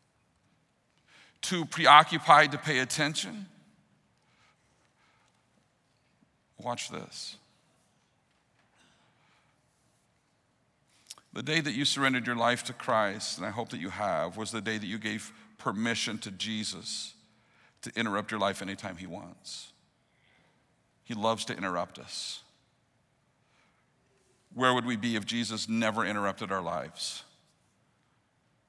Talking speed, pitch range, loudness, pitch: 110 wpm, 110-135 Hz, -29 LUFS, 120 Hz